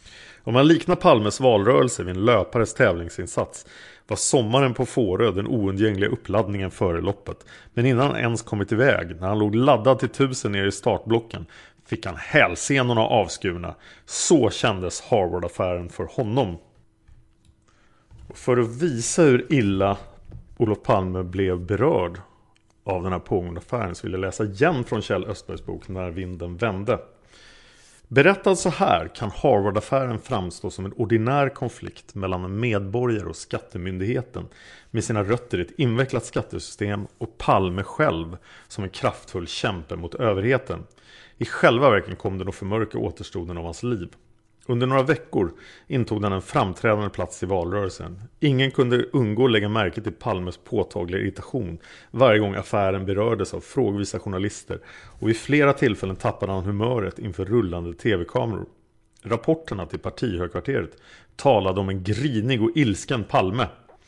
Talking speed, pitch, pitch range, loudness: 150 wpm, 105 Hz, 95-125 Hz, -23 LUFS